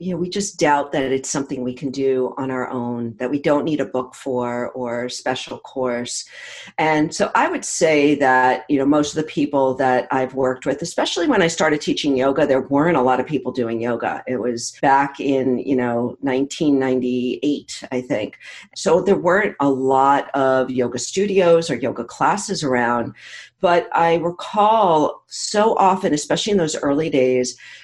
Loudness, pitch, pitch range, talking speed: -19 LUFS, 135 Hz, 125-155 Hz, 185 wpm